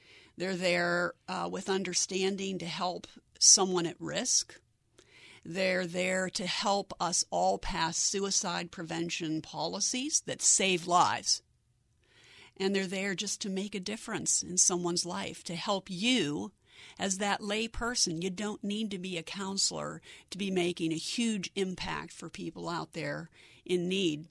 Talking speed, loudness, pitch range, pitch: 150 wpm, -30 LUFS, 175-195 Hz, 185 Hz